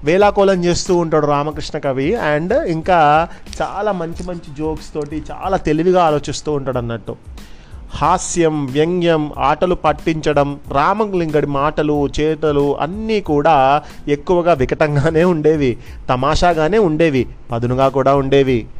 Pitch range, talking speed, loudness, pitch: 140-170 Hz, 110 wpm, -16 LUFS, 155 Hz